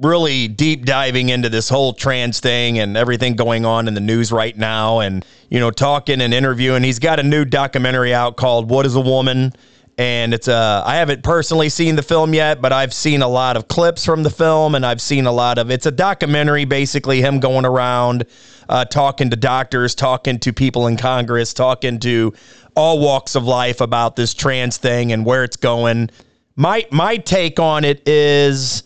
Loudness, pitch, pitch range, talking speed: -15 LUFS, 130 Hz, 120-145 Hz, 200 wpm